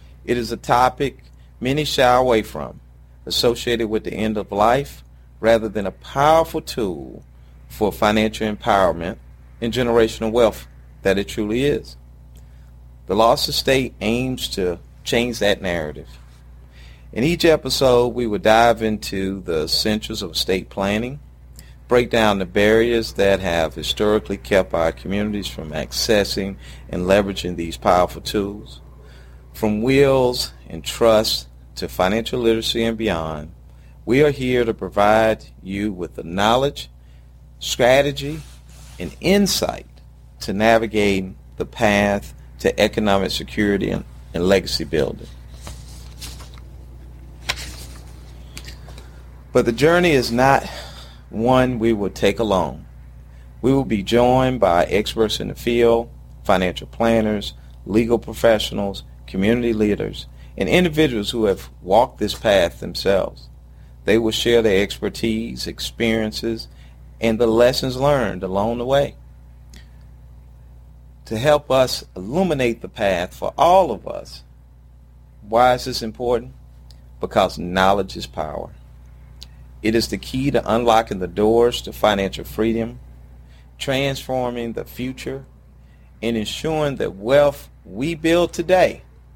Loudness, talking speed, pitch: -19 LUFS, 125 wpm, 100 Hz